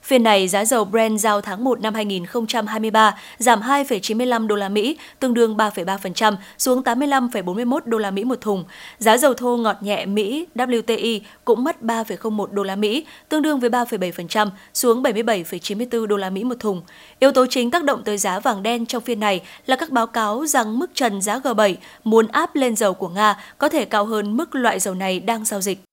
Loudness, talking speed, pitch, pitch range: -20 LUFS, 200 wpm, 225 Hz, 205-245 Hz